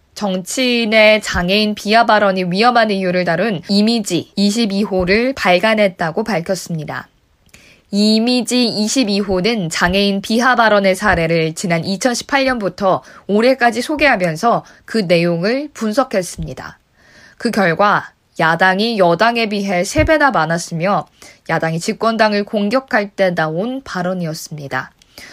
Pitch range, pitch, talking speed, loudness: 180-230 Hz, 205 Hz, 270 characters per minute, -15 LUFS